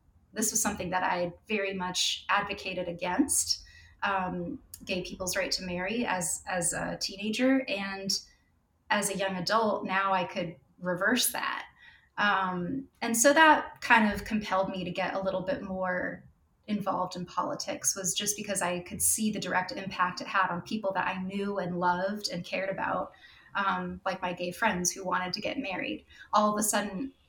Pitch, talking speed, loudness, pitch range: 190 Hz, 180 wpm, -29 LUFS, 180-210 Hz